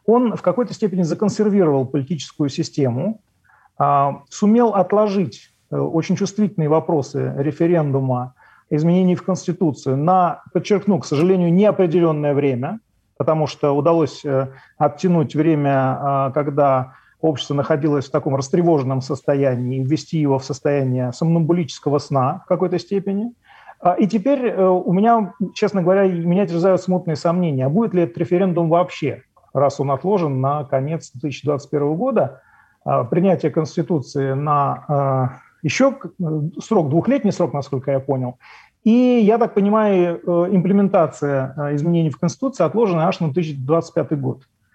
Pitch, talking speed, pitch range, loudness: 165 Hz, 120 wpm, 140-185 Hz, -19 LUFS